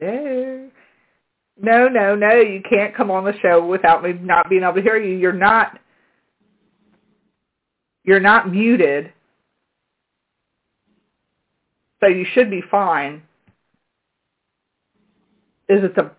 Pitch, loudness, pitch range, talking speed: 195 Hz, -16 LUFS, 180-225 Hz, 115 wpm